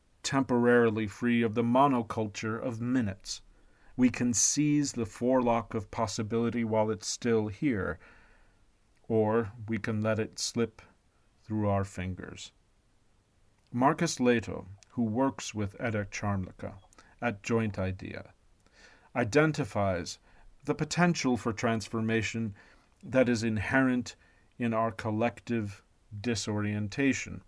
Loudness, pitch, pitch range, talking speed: -30 LUFS, 110 Hz, 100-120 Hz, 105 wpm